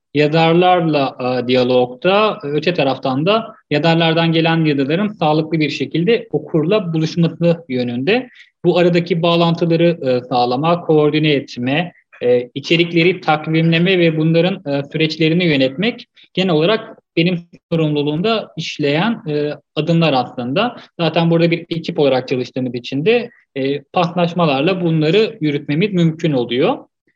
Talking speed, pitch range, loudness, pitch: 115 wpm, 145-175 Hz, -16 LUFS, 160 Hz